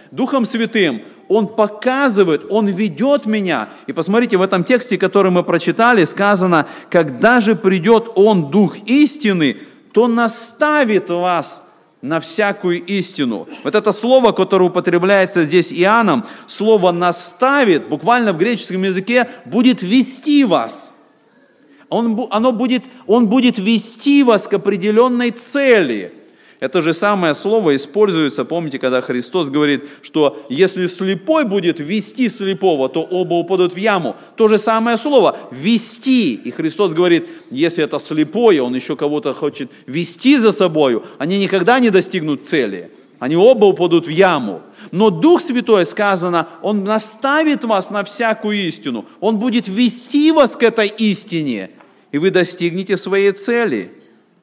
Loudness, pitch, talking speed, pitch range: -15 LUFS, 205 Hz, 135 wpm, 180-235 Hz